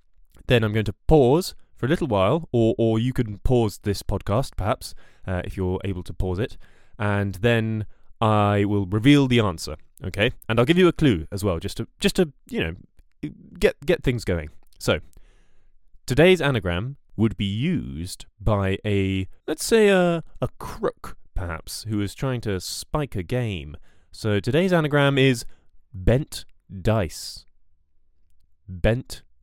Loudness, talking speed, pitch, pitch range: -23 LUFS, 160 wpm, 105 Hz, 95-125 Hz